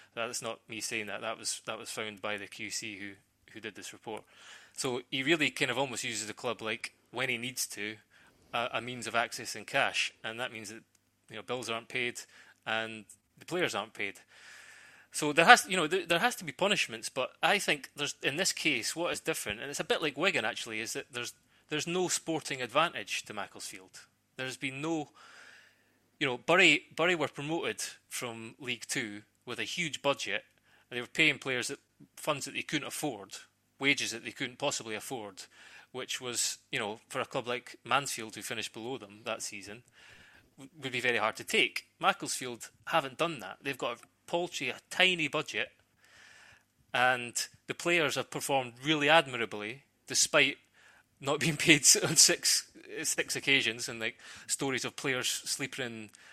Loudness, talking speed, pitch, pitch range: -31 LUFS, 190 wpm, 125 Hz, 110-140 Hz